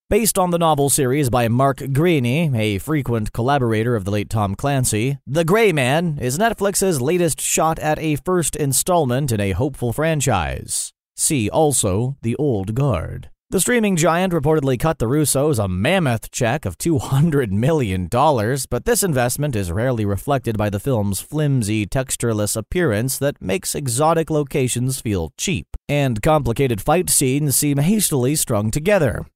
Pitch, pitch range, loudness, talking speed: 135 Hz, 115-155 Hz, -19 LUFS, 155 wpm